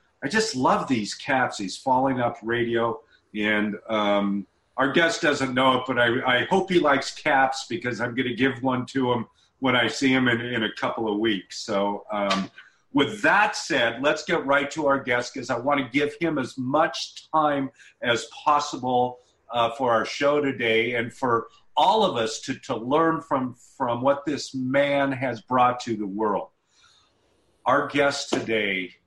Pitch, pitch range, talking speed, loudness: 125 Hz, 115-140 Hz, 185 wpm, -24 LUFS